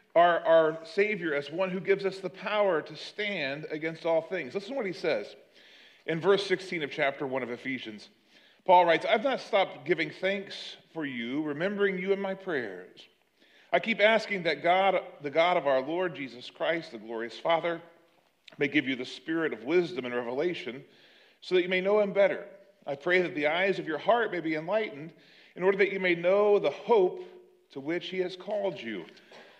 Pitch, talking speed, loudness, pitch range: 180 Hz, 200 wpm, -28 LUFS, 155-195 Hz